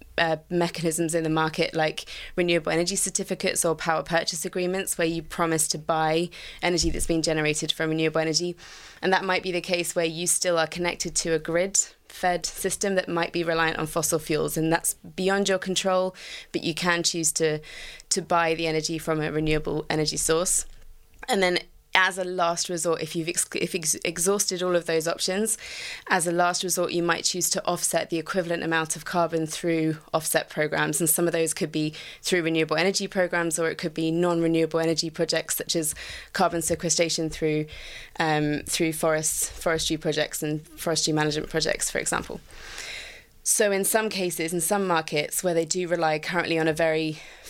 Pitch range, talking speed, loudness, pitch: 160-180 Hz, 190 wpm, -25 LUFS, 165 Hz